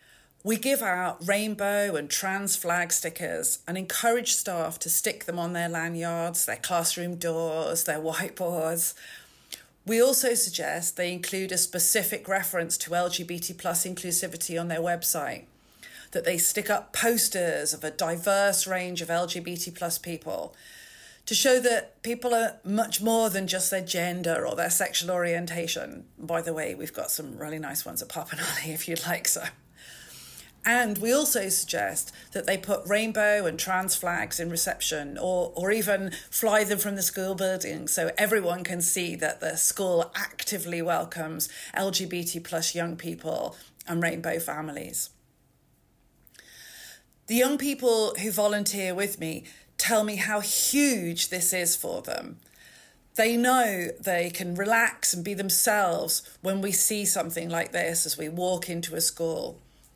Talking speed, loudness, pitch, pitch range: 155 wpm, -26 LUFS, 180 Hz, 170-210 Hz